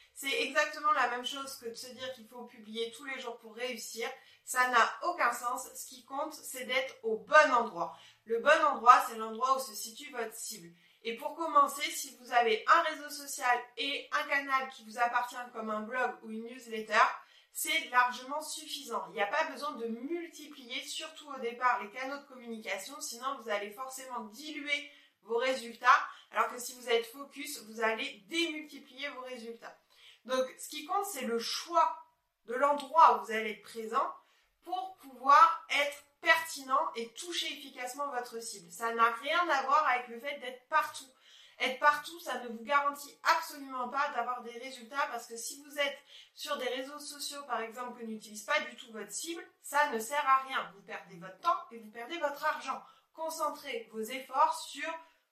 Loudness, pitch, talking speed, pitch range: -32 LUFS, 260 Hz, 190 wpm, 235-295 Hz